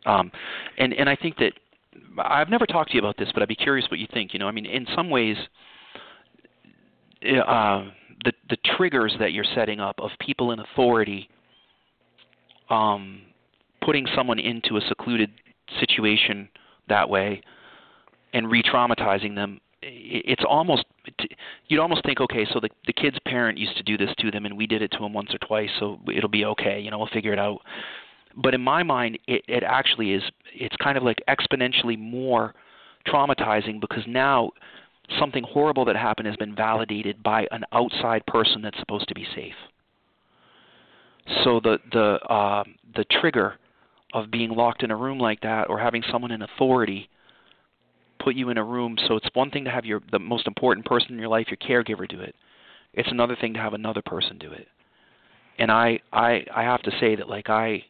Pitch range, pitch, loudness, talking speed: 105-120 Hz, 110 Hz, -24 LUFS, 185 wpm